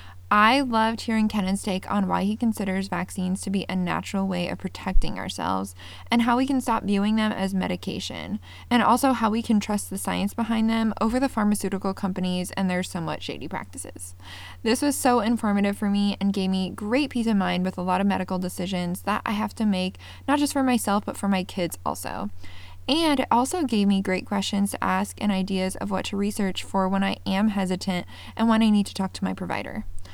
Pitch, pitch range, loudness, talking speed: 195 Hz, 185-220 Hz, -25 LUFS, 215 wpm